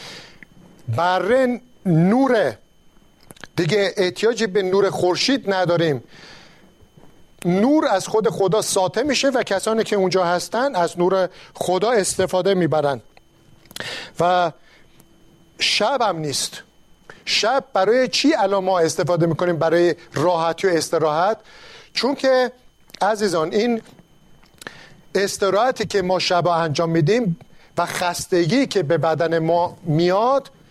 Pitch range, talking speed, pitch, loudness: 170-215 Hz, 110 wpm, 185 Hz, -19 LUFS